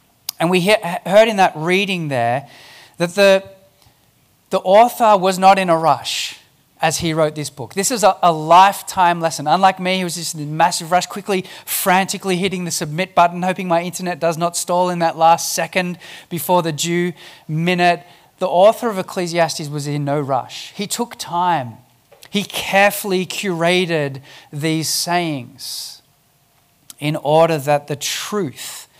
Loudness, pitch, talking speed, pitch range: -17 LUFS, 175 Hz, 160 wpm, 155-185 Hz